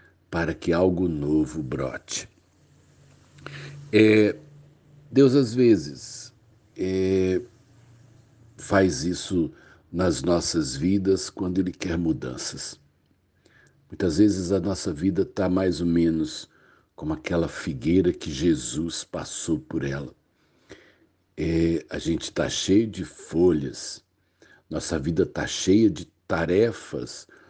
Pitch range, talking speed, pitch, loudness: 85-120 Hz, 105 wpm, 95 Hz, -24 LUFS